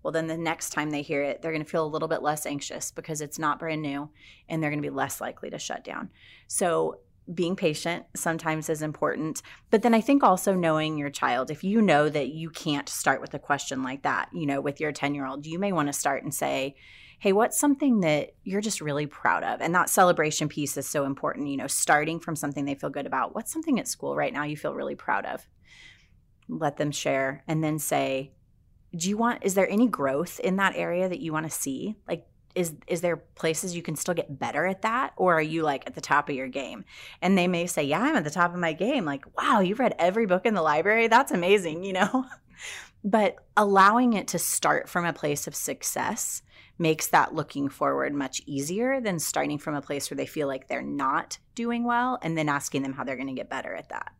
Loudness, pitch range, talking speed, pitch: -27 LUFS, 145-190 Hz, 240 wpm, 160 Hz